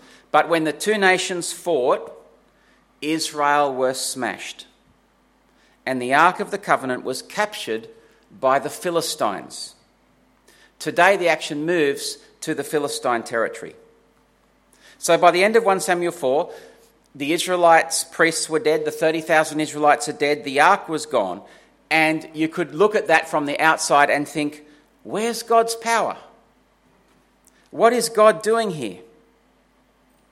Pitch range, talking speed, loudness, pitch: 150-210 Hz, 135 wpm, -20 LUFS, 165 Hz